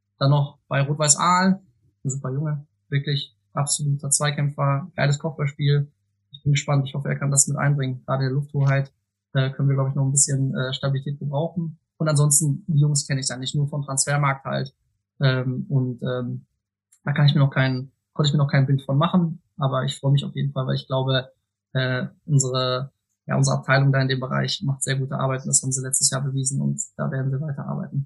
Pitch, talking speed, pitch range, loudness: 140 Hz, 215 wpm, 130-145 Hz, -22 LUFS